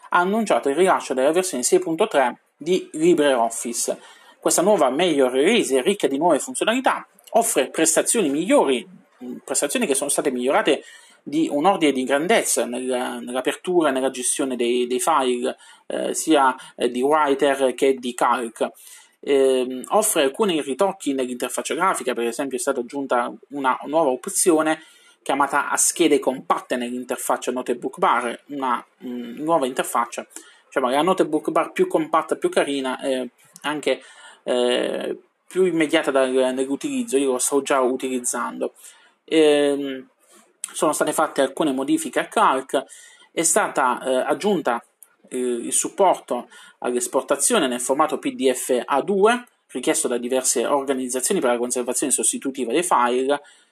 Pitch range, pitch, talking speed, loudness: 125-175 Hz, 140 Hz, 135 wpm, -21 LUFS